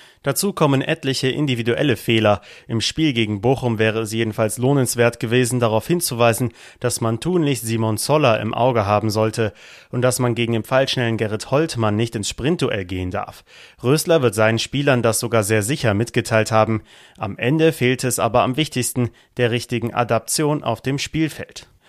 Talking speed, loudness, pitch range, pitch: 165 wpm, -19 LUFS, 110-130 Hz, 120 Hz